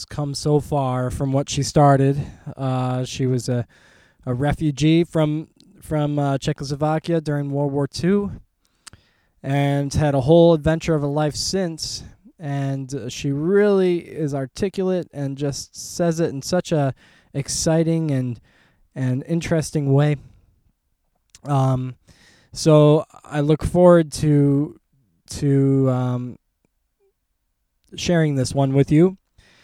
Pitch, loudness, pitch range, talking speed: 145 Hz, -20 LUFS, 135-160 Hz, 125 wpm